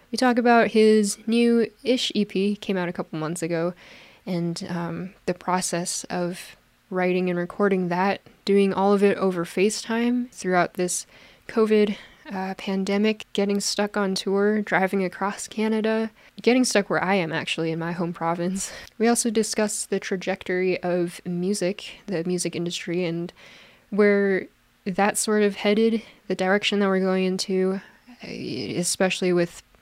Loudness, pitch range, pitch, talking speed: -24 LUFS, 180-210 Hz, 195 Hz, 150 wpm